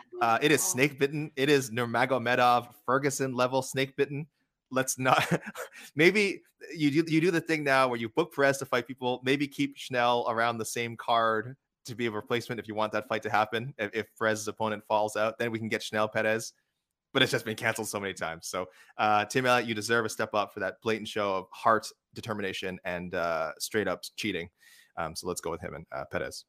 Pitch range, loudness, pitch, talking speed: 110-135 Hz, -29 LUFS, 120 Hz, 220 wpm